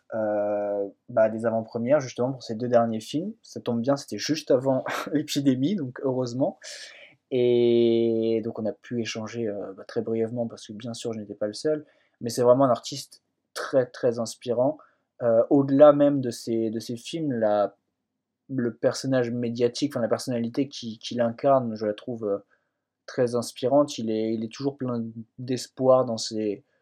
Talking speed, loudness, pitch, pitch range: 170 wpm, -25 LUFS, 120 Hz, 115-130 Hz